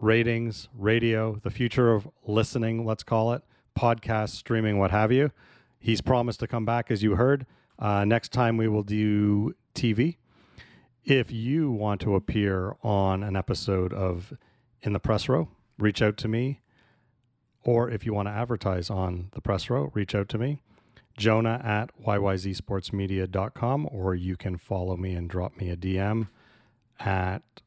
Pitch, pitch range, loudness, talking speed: 110 Hz, 100-120 Hz, -27 LUFS, 160 wpm